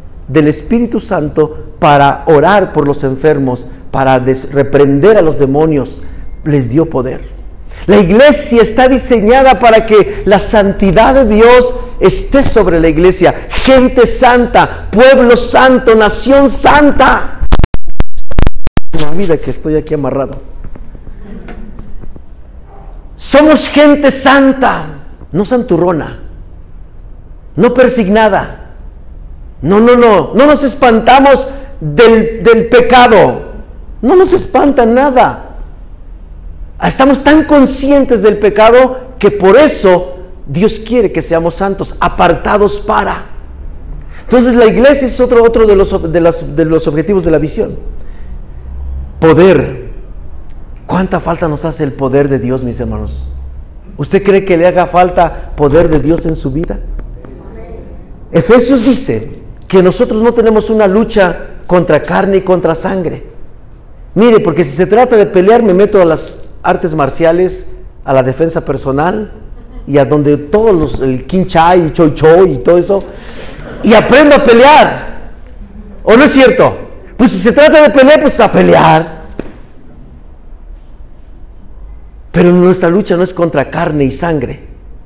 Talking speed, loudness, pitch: 130 wpm, -8 LUFS, 180 Hz